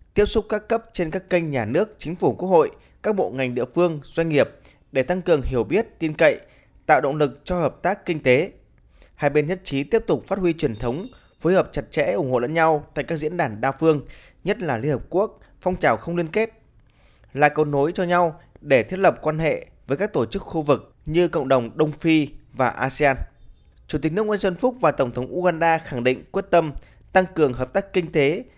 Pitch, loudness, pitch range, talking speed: 160 Hz, -22 LUFS, 135-180 Hz, 235 wpm